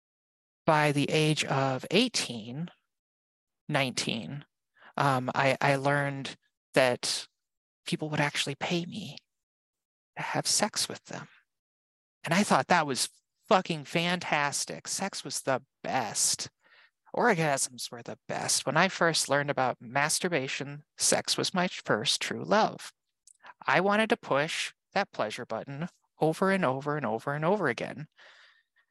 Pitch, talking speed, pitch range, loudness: 145 Hz, 130 wpm, 135-175 Hz, -28 LUFS